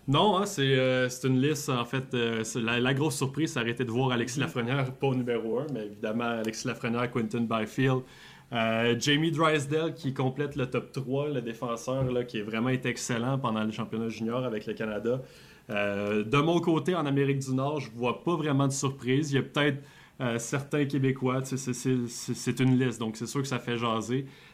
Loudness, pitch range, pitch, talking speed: -29 LUFS, 120-140 Hz, 130 Hz, 220 wpm